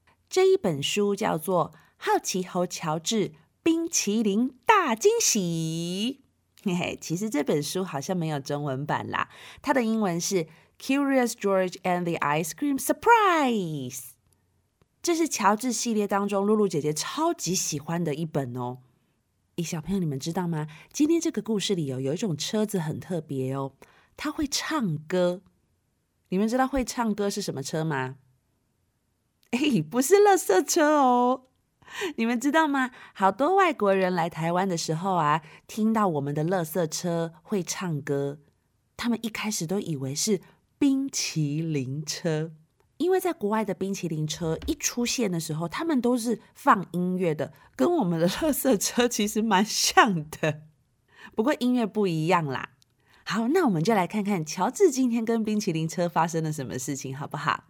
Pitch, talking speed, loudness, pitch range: 185 Hz, 265 characters per minute, -26 LUFS, 155-235 Hz